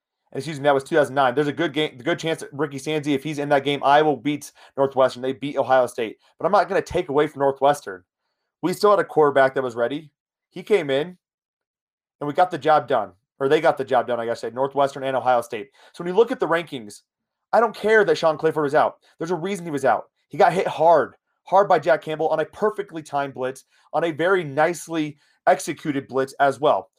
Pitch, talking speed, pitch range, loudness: 150 Hz, 240 wpm, 135-160 Hz, -21 LUFS